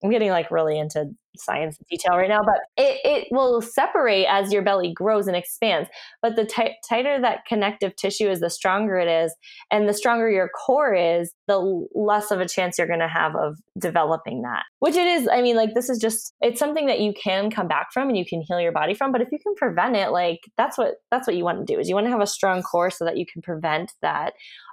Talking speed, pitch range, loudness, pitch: 255 wpm, 175-235 Hz, -22 LUFS, 205 Hz